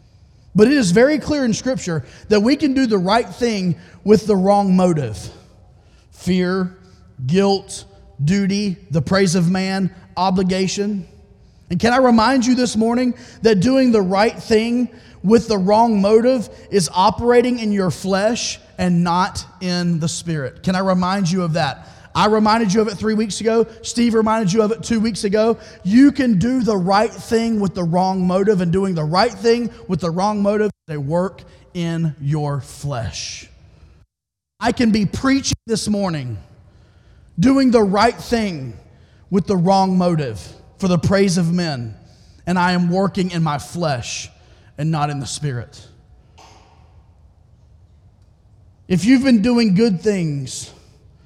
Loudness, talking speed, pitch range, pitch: -18 LUFS, 160 wpm, 150-220 Hz, 190 Hz